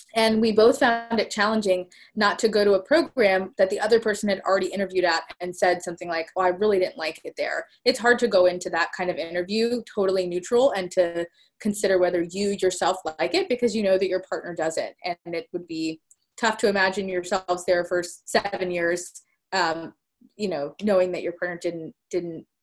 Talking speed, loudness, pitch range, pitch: 210 wpm, -24 LUFS, 180-215 Hz, 190 Hz